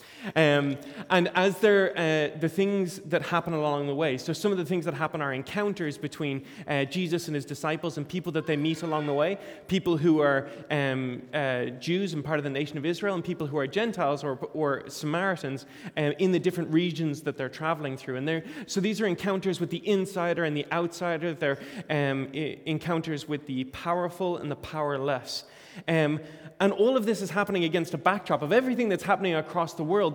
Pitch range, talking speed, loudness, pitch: 145-180 Hz, 205 wpm, -28 LUFS, 165 Hz